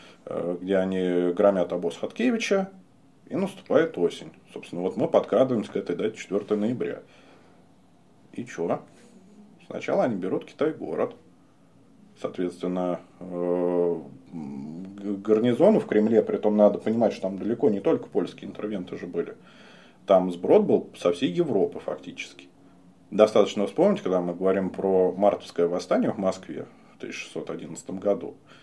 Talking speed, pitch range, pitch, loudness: 125 wpm, 90-105 Hz, 95 Hz, -25 LUFS